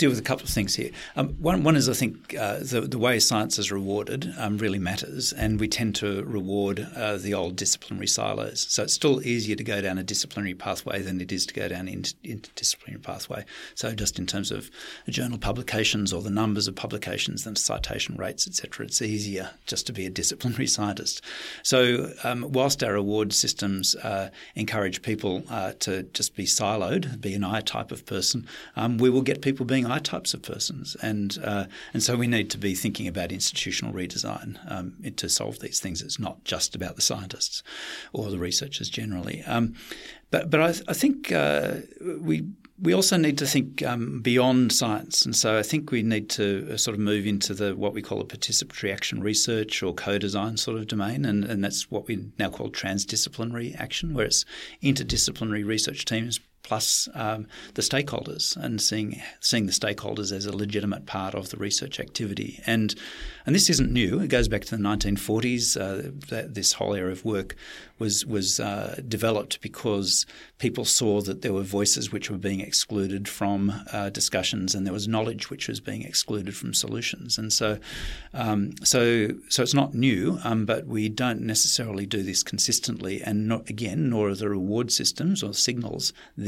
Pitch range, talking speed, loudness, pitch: 100-120 Hz, 190 wpm, -26 LUFS, 110 Hz